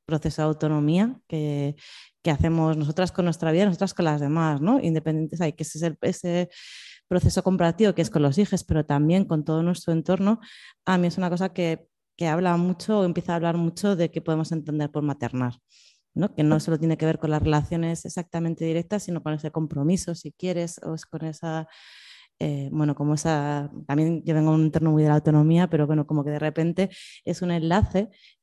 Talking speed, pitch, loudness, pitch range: 205 wpm, 165 Hz, -24 LUFS, 155-180 Hz